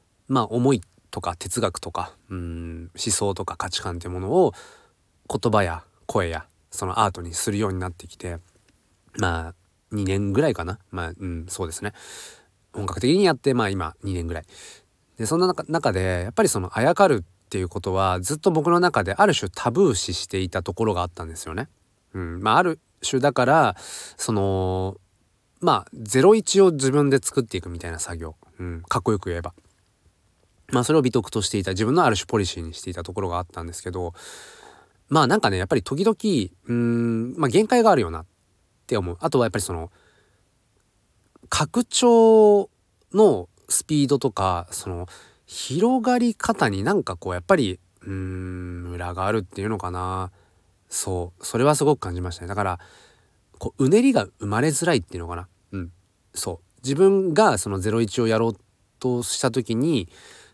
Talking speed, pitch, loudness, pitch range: 340 characters per minute, 100 Hz, -22 LUFS, 90-125 Hz